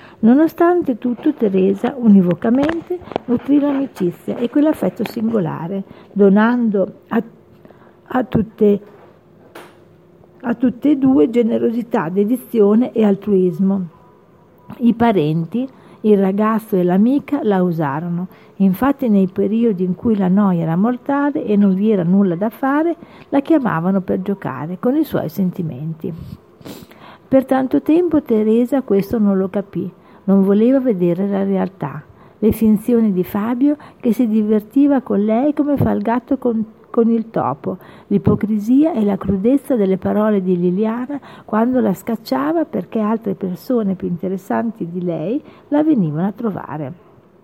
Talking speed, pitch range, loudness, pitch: 135 wpm, 195-245 Hz, -17 LUFS, 215 Hz